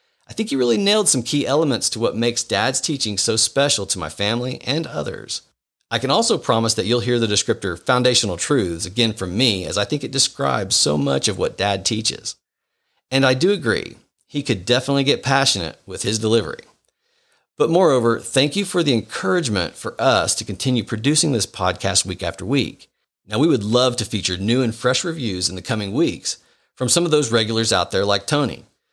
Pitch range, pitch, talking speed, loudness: 105-135 Hz, 120 Hz, 200 wpm, -19 LUFS